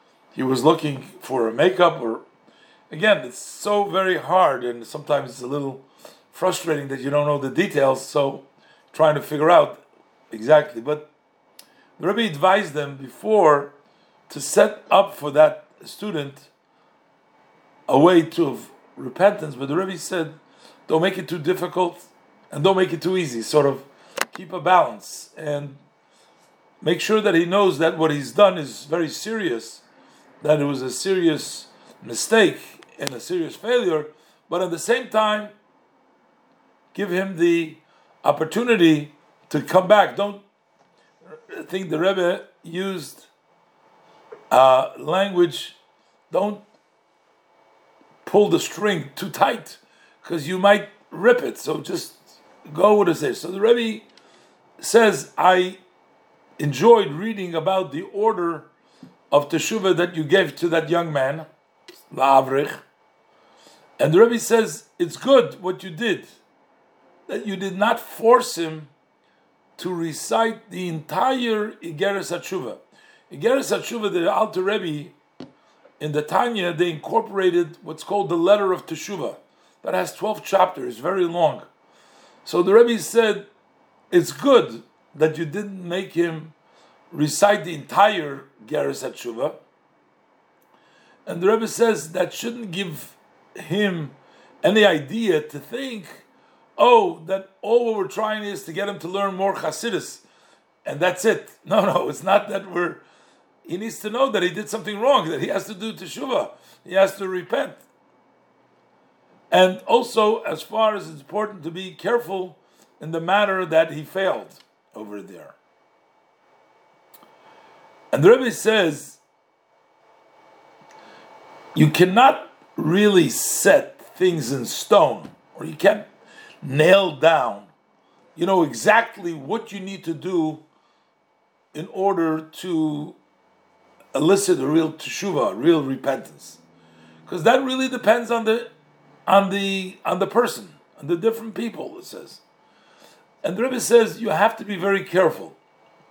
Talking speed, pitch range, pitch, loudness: 140 wpm, 155-210 Hz, 185 Hz, -21 LUFS